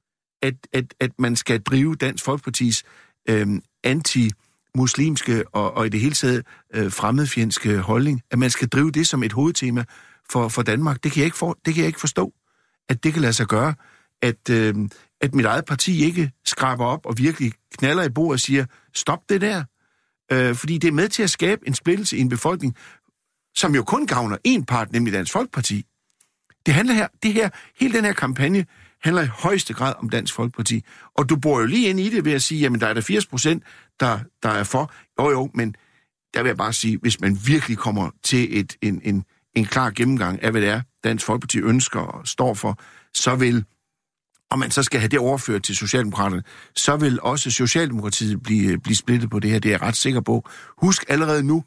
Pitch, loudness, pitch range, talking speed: 125 Hz, -21 LUFS, 115-150 Hz, 215 wpm